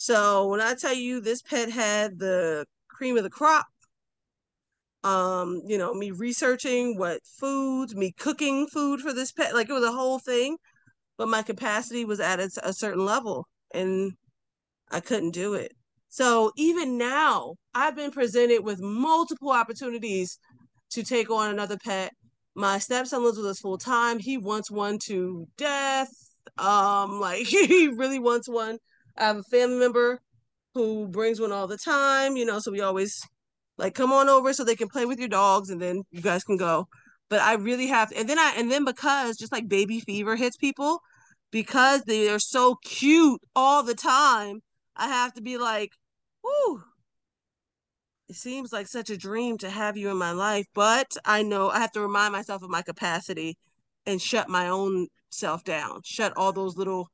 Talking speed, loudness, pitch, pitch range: 185 wpm, -25 LUFS, 220 Hz, 195-255 Hz